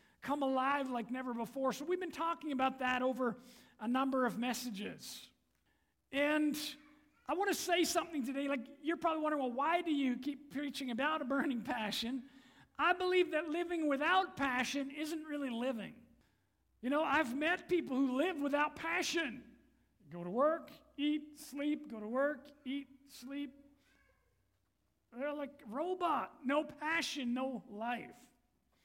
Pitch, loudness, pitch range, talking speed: 280 Hz, -37 LUFS, 260-305 Hz, 155 wpm